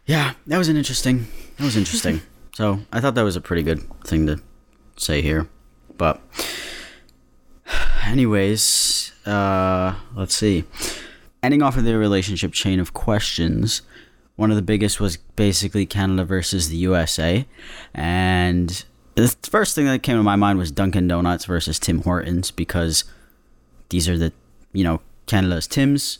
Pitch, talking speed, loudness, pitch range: 95 Hz, 150 wpm, -20 LUFS, 85-110 Hz